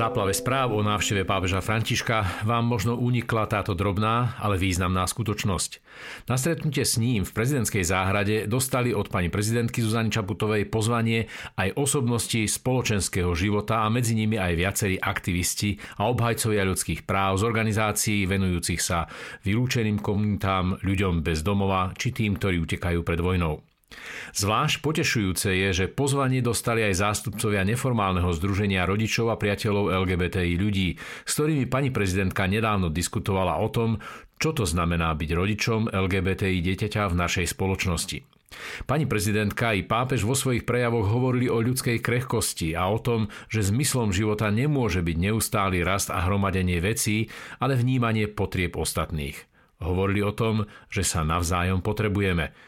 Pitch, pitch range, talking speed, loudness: 105 Hz, 95-115 Hz, 140 wpm, -25 LUFS